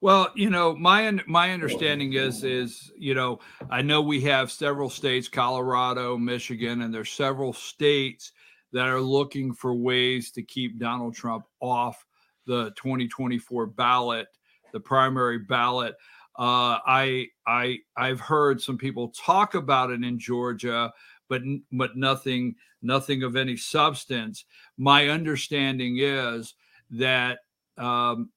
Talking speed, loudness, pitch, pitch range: 130 wpm, -25 LUFS, 130 Hz, 120-140 Hz